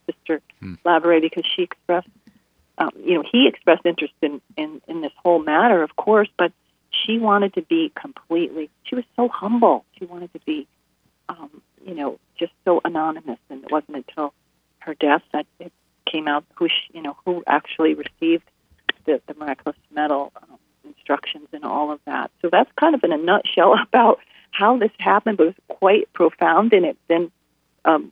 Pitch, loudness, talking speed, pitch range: 170 Hz, -20 LUFS, 180 wpm, 155-220 Hz